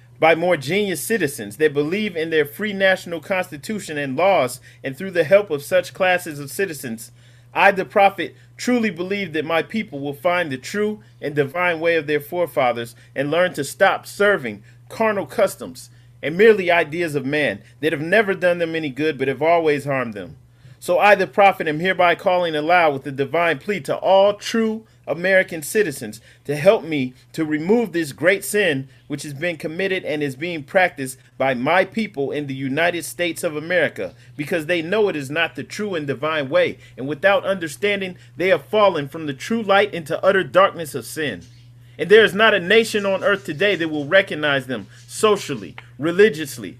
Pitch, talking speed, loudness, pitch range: 165 Hz, 190 wpm, -19 LUFS, 140-195 Hz